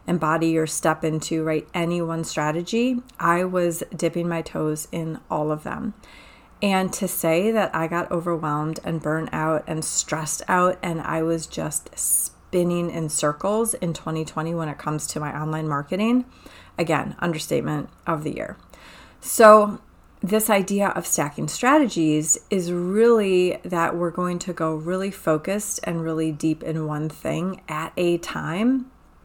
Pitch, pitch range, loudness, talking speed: 170 Hz, 160-185 Hz, -23 LUFS, 155 wpm